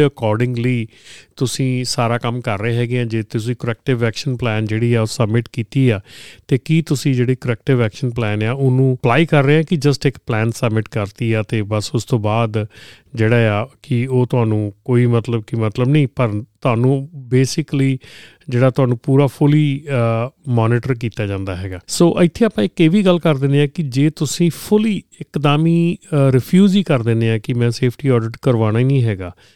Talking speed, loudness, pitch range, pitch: 185 wpm, -17 LUFS, 115-140 Hz, 125 Hz